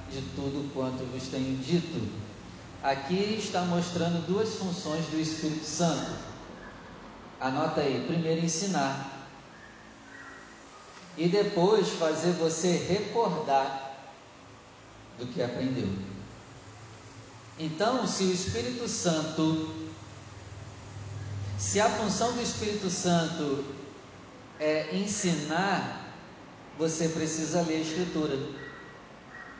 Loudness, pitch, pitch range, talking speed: -30 LUFS, 155 Hz, 125-175 Hz, 90 wpm